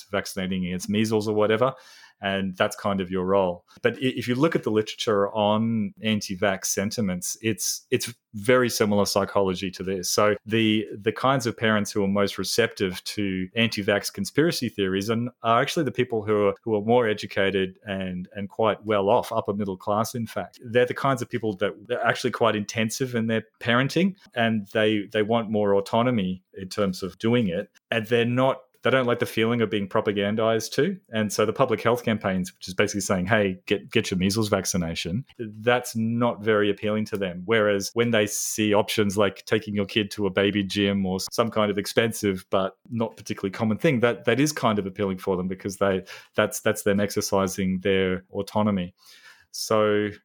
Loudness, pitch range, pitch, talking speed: -24 LUFS, 100-115 Hz, 105 Hz, 190 wpm